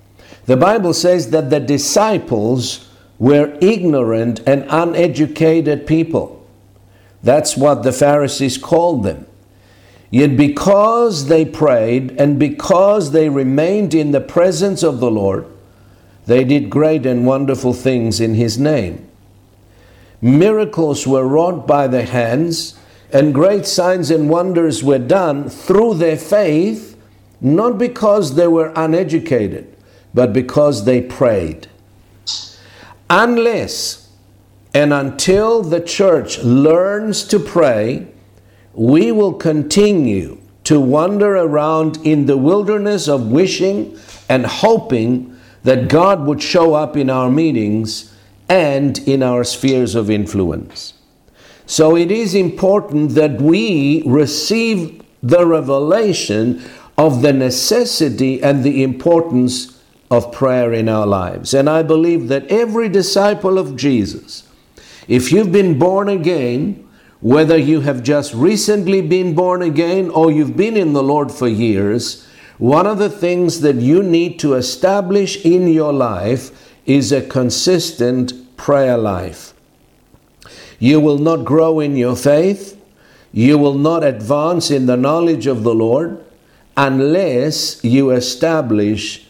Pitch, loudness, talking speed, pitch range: 145 Hz, -14 LUFS, 125 wpm, 125-170 Hz